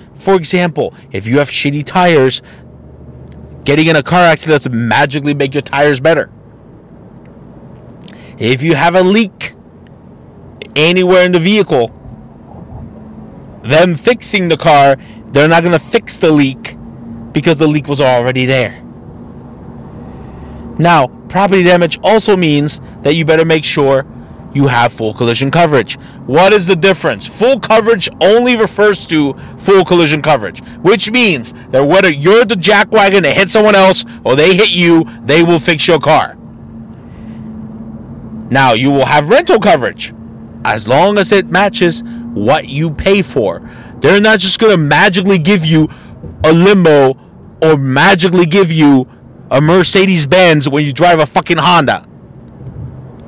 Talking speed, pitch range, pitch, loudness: 145 wpm, 135-190 Hz, 160 Hz, -9 LUFS